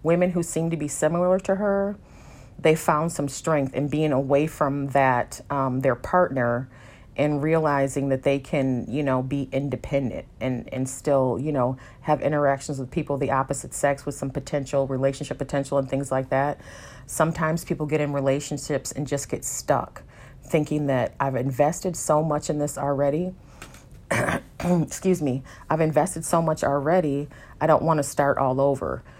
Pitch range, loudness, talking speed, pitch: 135-155 Hz, -24 LUFS, 170 wpm, 140 Hz